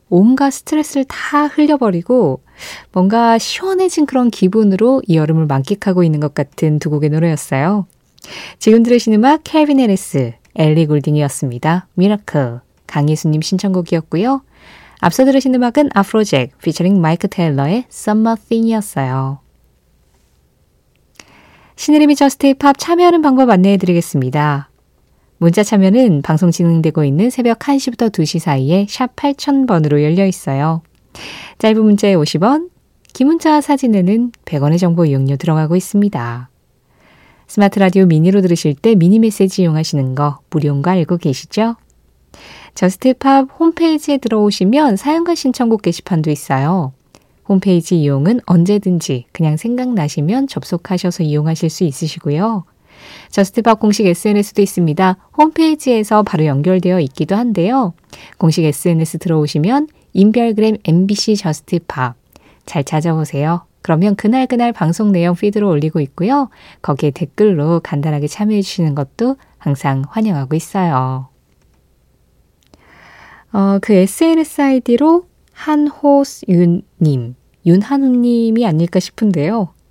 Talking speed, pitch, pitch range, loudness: 320 characters per minute, 190 Hz, 155-235 Hz, -14 LUFS